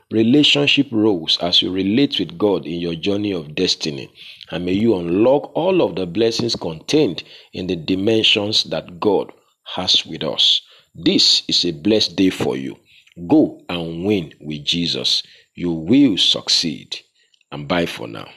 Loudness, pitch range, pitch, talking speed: -17 LUFS, 85-115 Hz, 100 Hz, 155 wpm